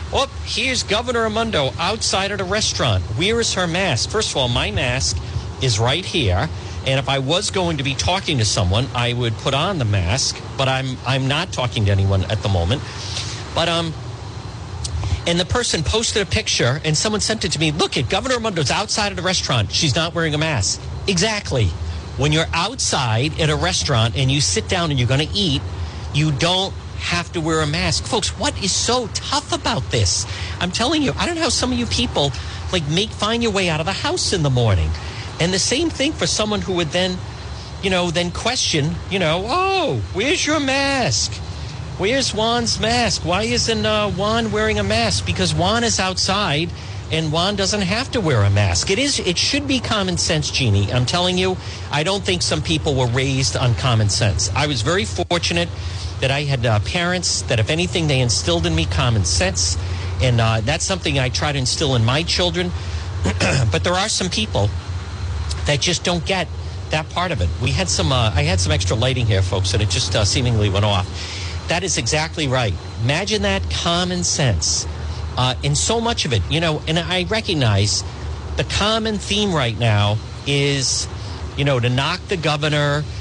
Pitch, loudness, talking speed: 120 Hz, -19 LUFS, 210 wpm